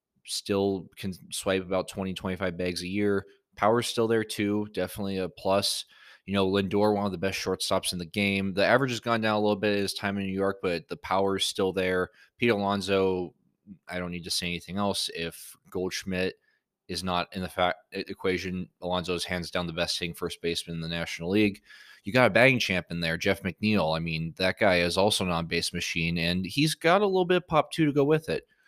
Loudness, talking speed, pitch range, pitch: -27 LUFS, 220 wpm, 90-100 Hz, 95 Hz